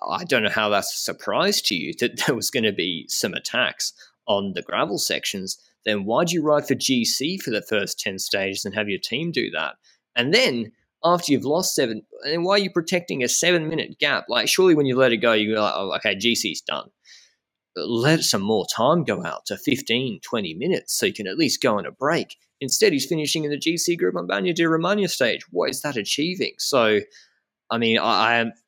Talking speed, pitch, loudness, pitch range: 230 wpm, 150 Hz, -22 LUFS, 115-175 Hz